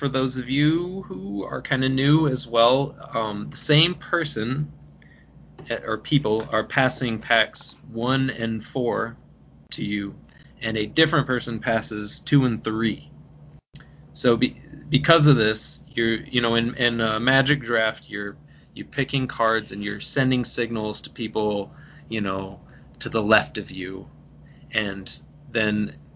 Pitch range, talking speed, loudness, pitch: 105-140 Hz, 155 wpm, -23 LUFS, 115 Hz